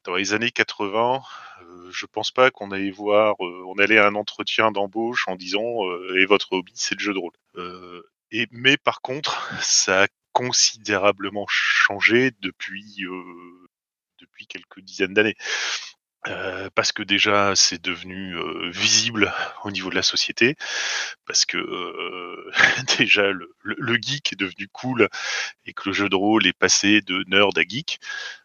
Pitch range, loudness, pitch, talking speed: 95-115 Hz, -21 LUFS, 105 Hz, 170 wpm